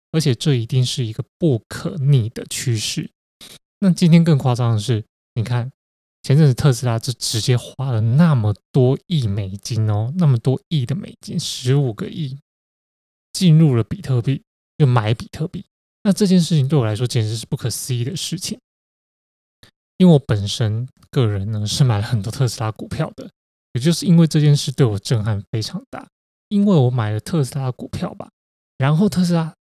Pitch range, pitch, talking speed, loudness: 115-160 Hz, 130 Hz, 270 characters per minute, -19 LUFS